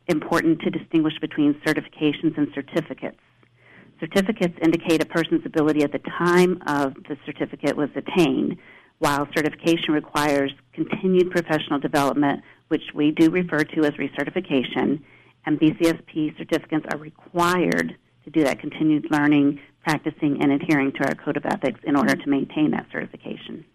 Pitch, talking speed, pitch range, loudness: 155 Hz, 145 wpm, 145-165 Hz, -22 LUFS